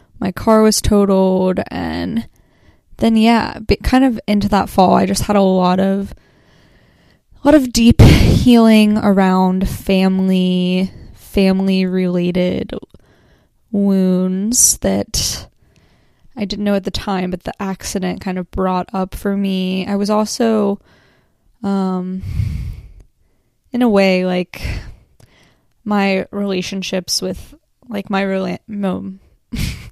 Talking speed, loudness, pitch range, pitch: 120 wpm, -15 LUFS, 185-210 Hz, 195 Hz